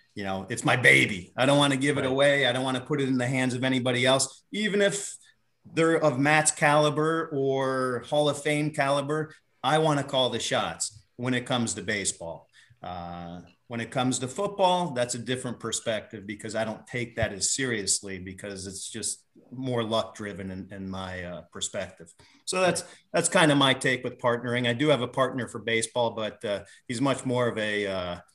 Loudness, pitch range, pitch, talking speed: -26 LUFS, 110-145 Hz, 125 Hz, 205 wpm